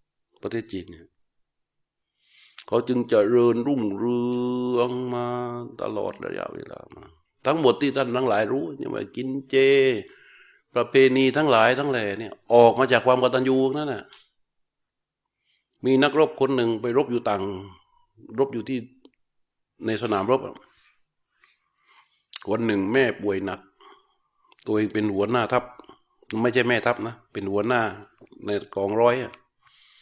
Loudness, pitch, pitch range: -23 LUFS, 125 Hz, 110-135 Hz